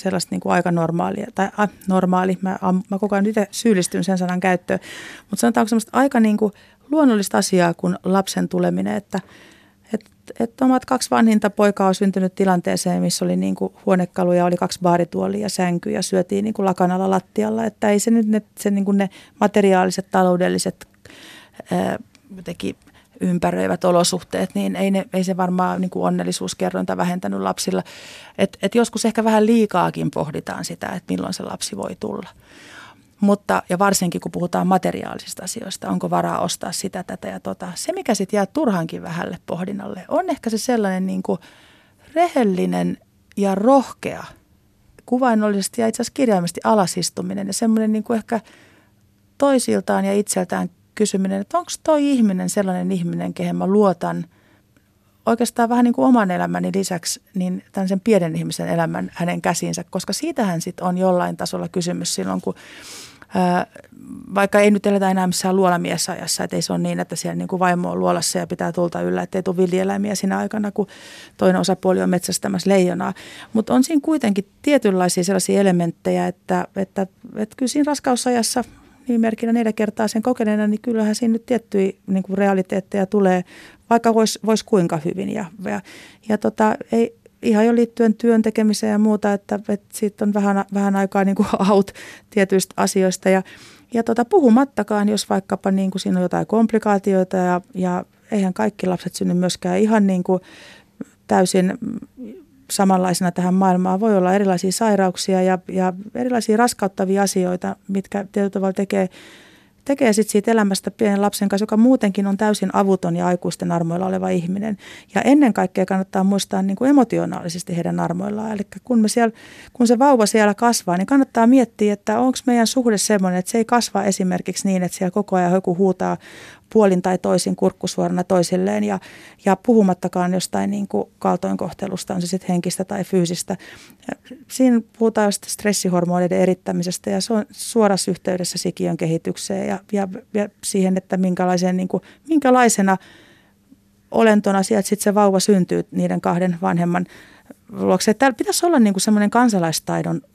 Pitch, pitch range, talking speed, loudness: 195 Hz, 180-215 Hz, 165 wpm, -19 LUFS